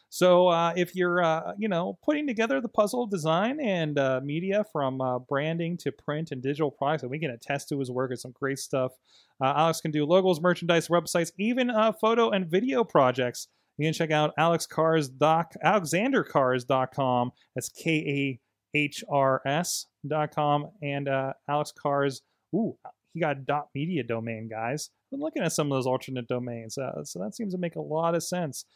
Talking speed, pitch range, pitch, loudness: 180 wpm, 135-175 Hz, 155 Hz, -27 LUFS